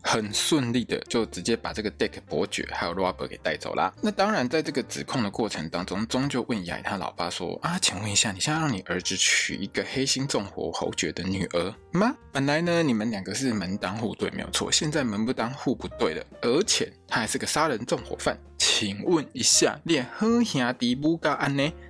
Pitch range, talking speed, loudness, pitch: 100-155 Hz, 330 characters per minute, -26 LUFS, 130 Hz